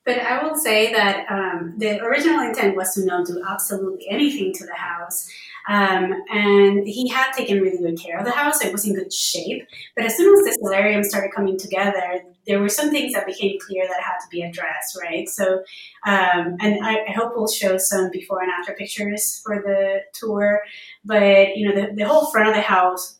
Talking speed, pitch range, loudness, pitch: 215 wpm, 190-210 Hz, -20 LUFS, 200 Hz